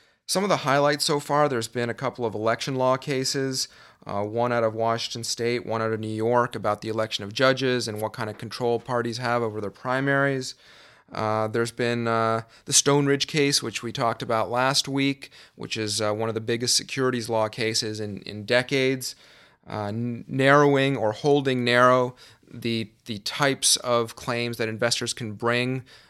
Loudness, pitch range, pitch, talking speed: -24 LUFS, 110-130 Hz, 120 Hz, 185 wpm